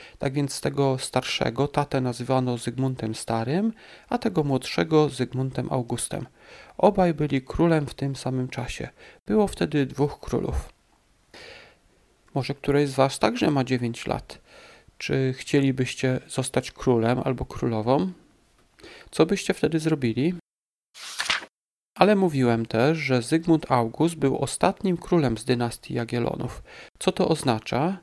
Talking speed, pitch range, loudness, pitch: 120 wpm, 125-155 Hz, -25 LUFS, 135 Hz